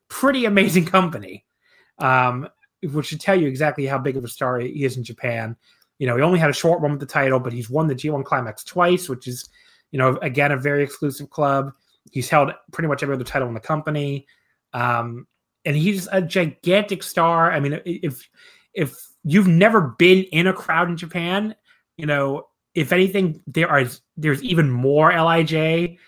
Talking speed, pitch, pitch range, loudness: 190 wpm, 150 Hz, 135-175 Hz, -20 LUFS